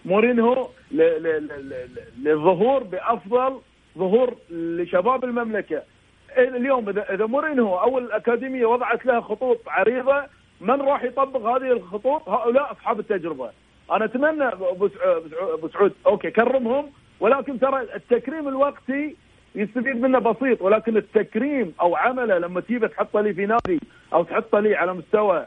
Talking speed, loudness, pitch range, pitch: 130 wpm, -22 LUFS, 205-265 Hz, 235 Hz